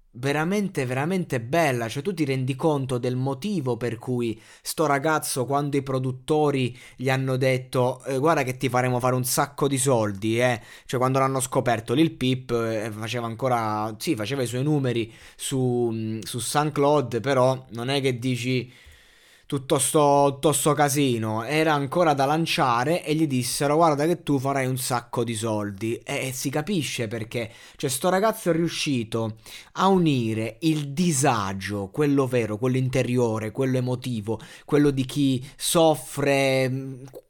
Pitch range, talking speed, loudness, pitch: 120-145 Hz, 155 wpm, -24 LUFS, 130 Hz